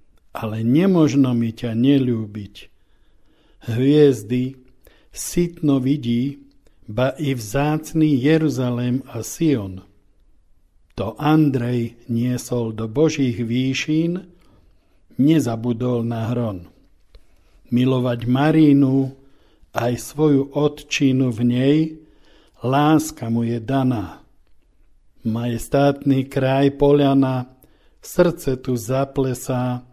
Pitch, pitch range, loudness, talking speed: 130 Hz, 120-145 Hz, -20 LUFS, 80 wpm